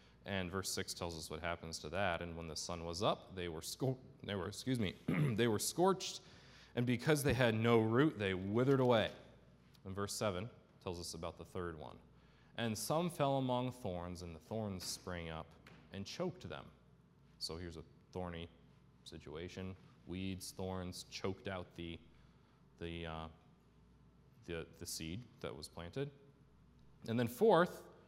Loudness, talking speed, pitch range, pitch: -39 LUFS, 165 wpm, 85-120 Hz, 95 Hz